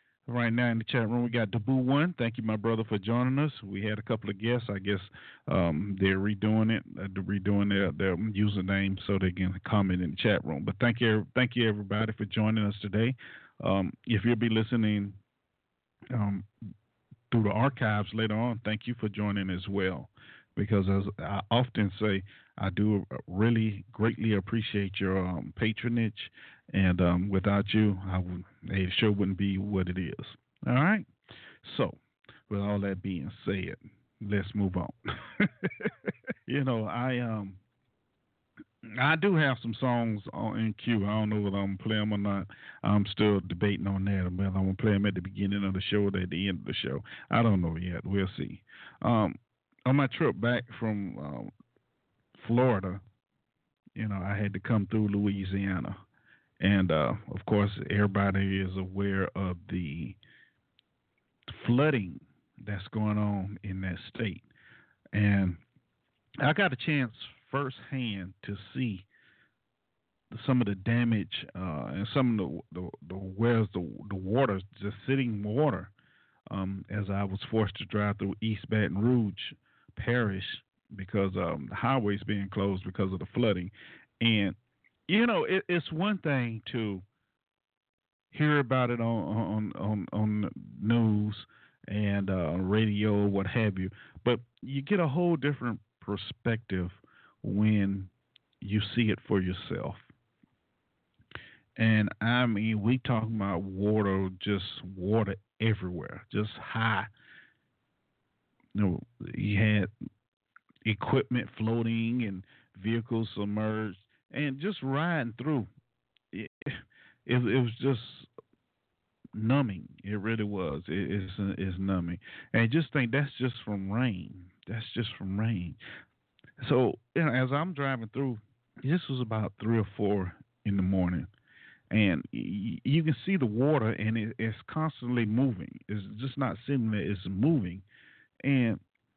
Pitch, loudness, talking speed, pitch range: 105 Hz, -30 LUFS, 155 wpm, 100-120 Hz